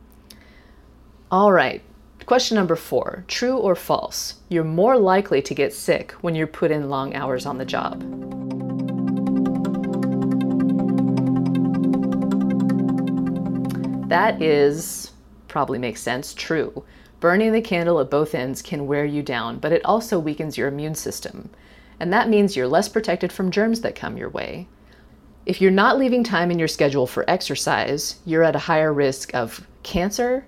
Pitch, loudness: 145 Hz, -21 LUFS